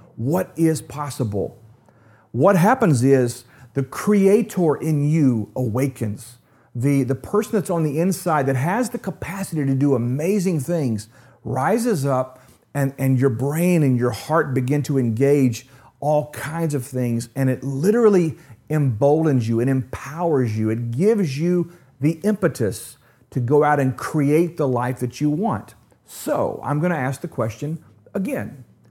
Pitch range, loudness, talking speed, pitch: 125-165 Hz, -21 LUFS, 150 wpm, 140 Hz